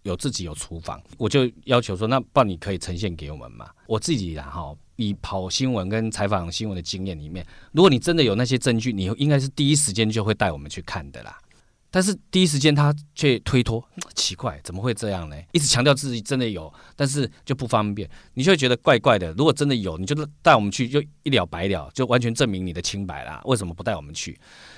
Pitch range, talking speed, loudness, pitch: 95-135 Hz, 345 characters per minute, -22 LUFS, 110 Hz